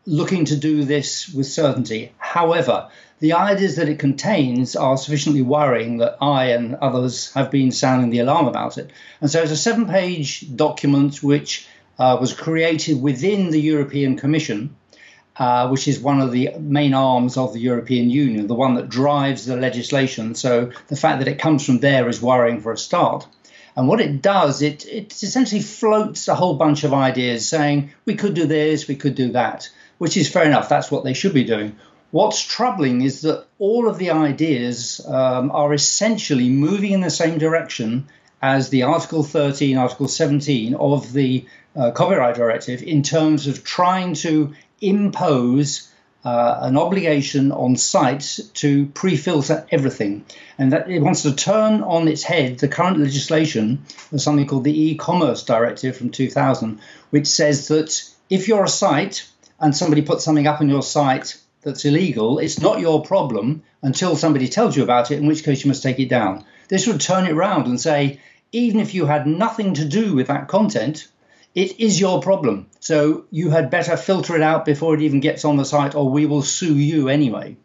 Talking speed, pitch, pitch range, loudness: 185 wpm, 145 Hz, 130-165 Hz, -18 LUFS